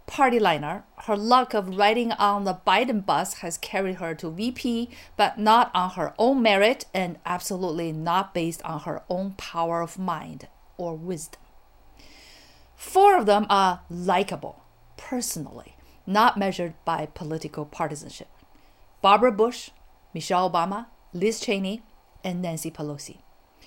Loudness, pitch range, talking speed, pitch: -24 LUFS, 170-215 Hz, 135 wpm, 190 Hz